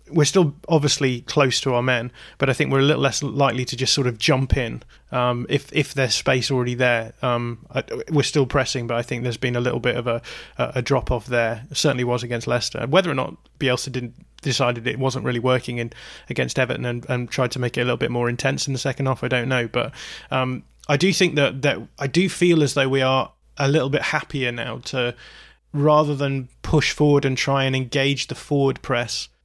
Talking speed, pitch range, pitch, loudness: 230 wpm, 125-145 Hz, 130 Hz, -21 LUFS